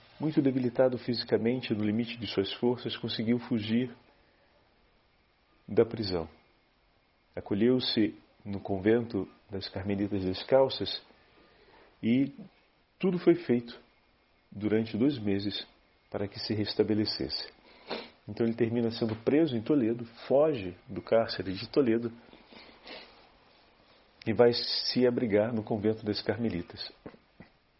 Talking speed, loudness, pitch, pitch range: 105 wpm, -30 LUFS, 115 Hz, 105-120 Hz